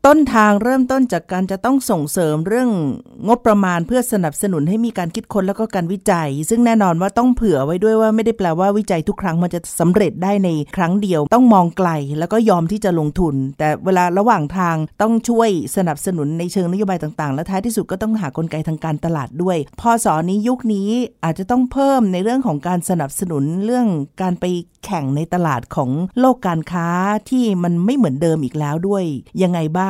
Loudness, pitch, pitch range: -17 LUFS, 185 Hz, 165-220 Hz